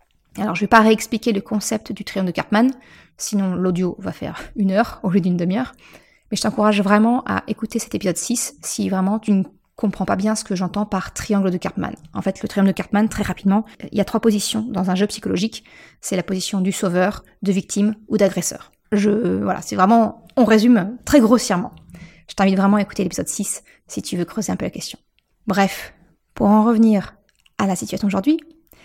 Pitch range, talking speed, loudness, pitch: 195-220 Hz, 215 wpm, -19 LUFS, 205 Hz